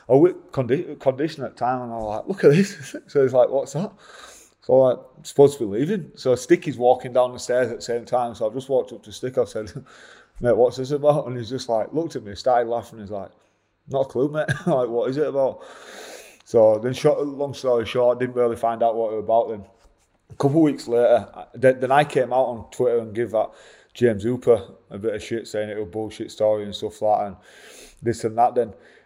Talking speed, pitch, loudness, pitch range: 250 wpm, 125 Hz, -22 LUFS, 115-140 Hz